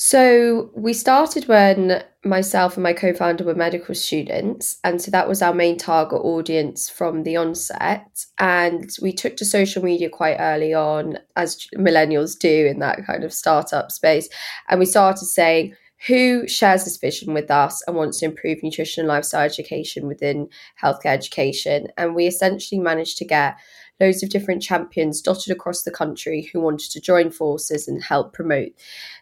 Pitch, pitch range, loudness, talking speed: 175 Hz, 155-190 Hz, -19 LUFS, 170 wpm